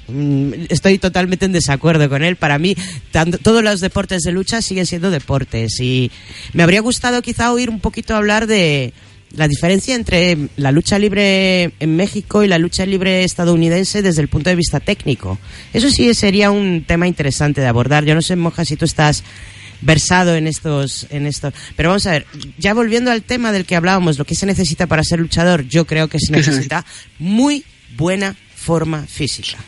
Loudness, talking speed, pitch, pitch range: -15 LUFS, 190 wpm, 170 Hz, 145-190 Hz